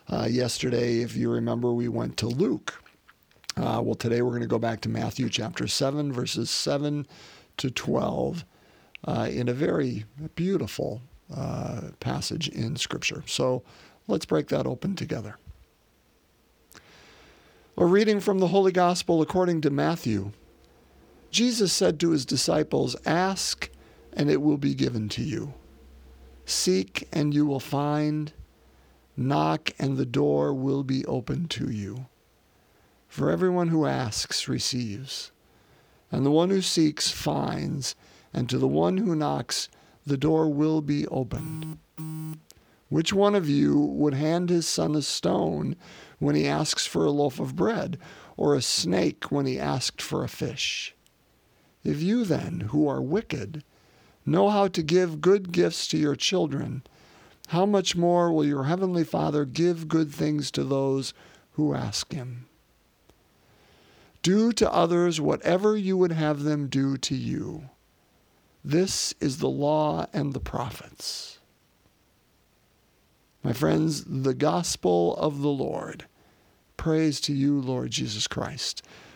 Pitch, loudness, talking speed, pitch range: 145 Hz, -26 LUFS, 140 wpm, 120-165 Hz